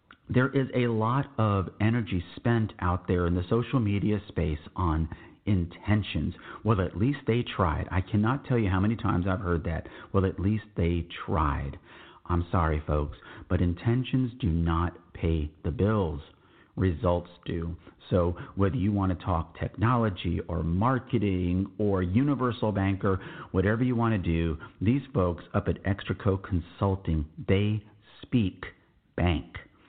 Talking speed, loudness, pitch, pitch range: 150 wpm, -28 LUFS, 95 Hz, 85-110 Hz